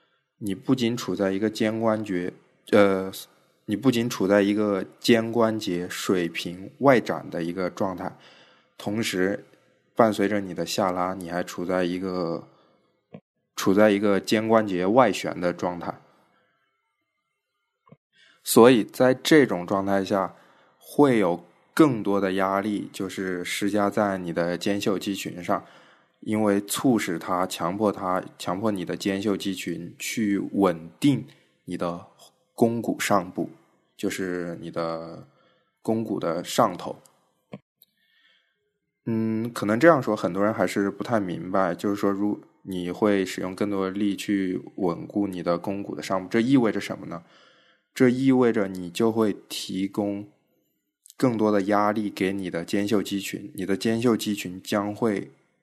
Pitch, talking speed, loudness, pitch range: 100 Hz, 205 characters per minute, -25 LUFS, 95-110 Hz